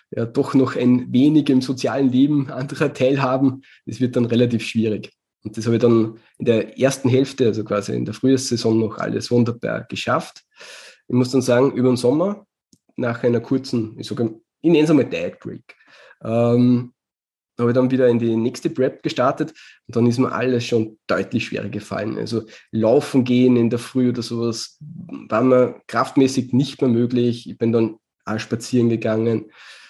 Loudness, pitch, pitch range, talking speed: -20 LUFS, 125 Hz, 115-130 Hz, 175 wpm